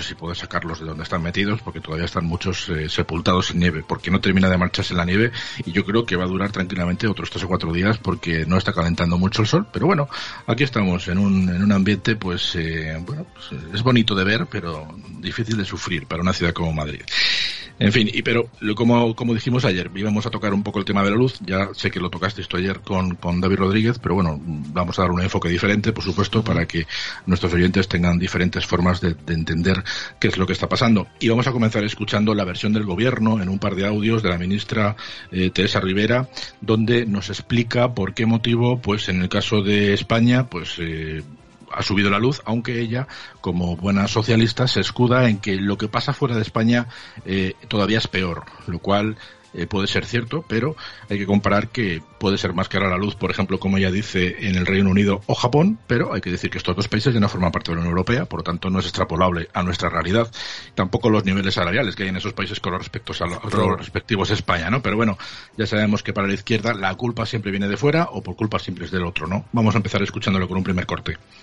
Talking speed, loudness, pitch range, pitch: 235 wpm, -21 LUFS, 90-110 Hz, 100 Hz